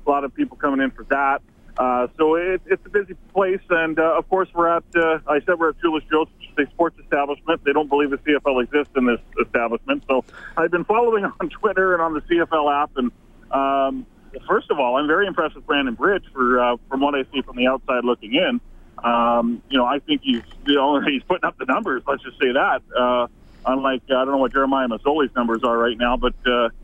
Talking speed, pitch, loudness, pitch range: 230 wpm, 140 Hz, -20 LUFS, 125-165 Hz